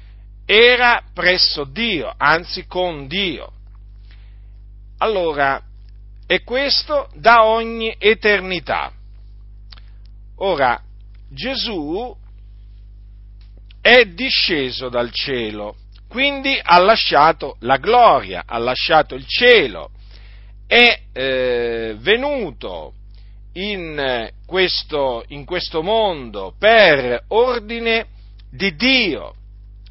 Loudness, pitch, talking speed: -16 LUFS, 130 Hz, 80 wpm